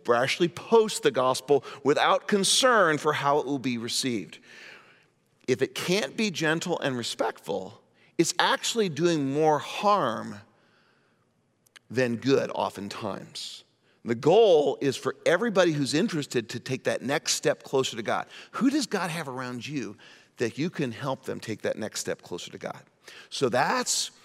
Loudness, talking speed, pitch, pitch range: -26 LUFS, 155 wpm, 150 Hz, 130-190 Hz